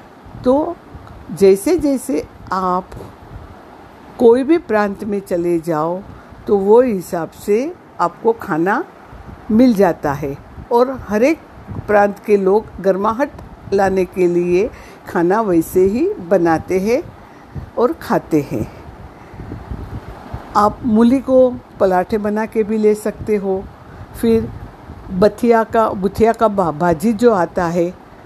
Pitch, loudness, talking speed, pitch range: 210 Hz, -16 LUFS, 120 wpm, 185-235 Hz